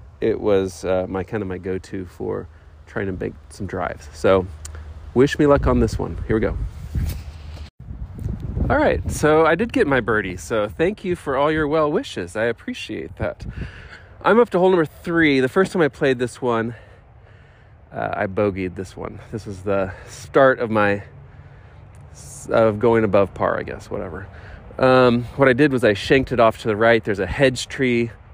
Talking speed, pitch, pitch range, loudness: 190 wpm, 110 Hz, 95-130 Hz, -20 LUFS